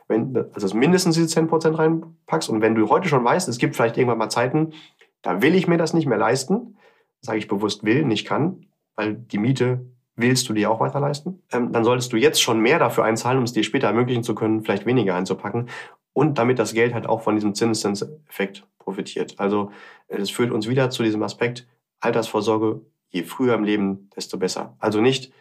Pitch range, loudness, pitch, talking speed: 110-140 Hz, -21 LUFS, 120 Hz, 205 wpm